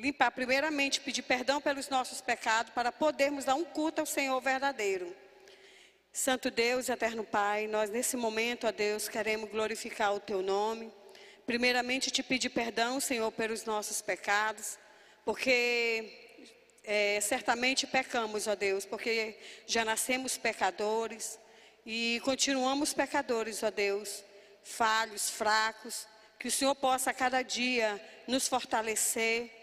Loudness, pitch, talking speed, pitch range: -31 LUFS, 230 Hz, 130 wpm, 215-255 Hz